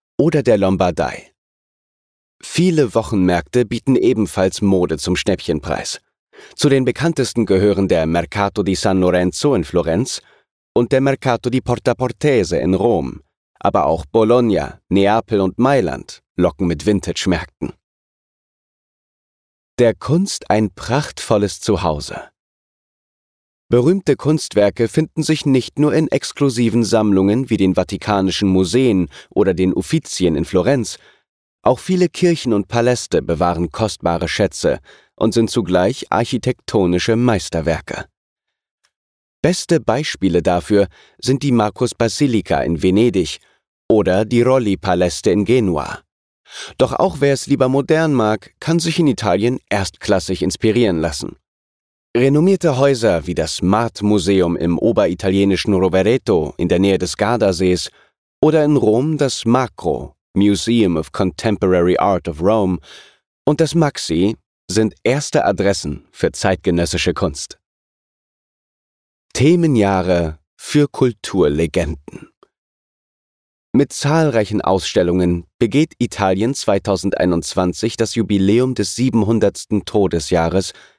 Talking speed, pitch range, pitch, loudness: 110 wpm, 90-125 Hz, 105 Hz, -17 LUFS